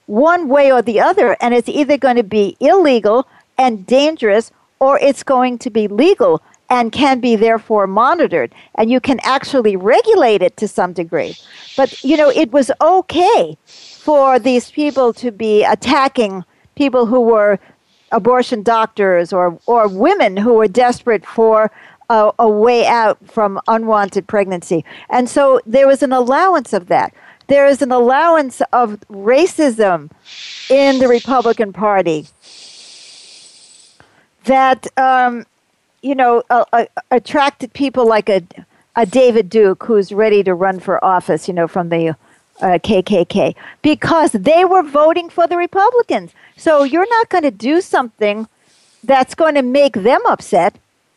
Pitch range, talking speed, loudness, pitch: 215-280 Hz, 150 wpm, -13 LUFS, 245 Hz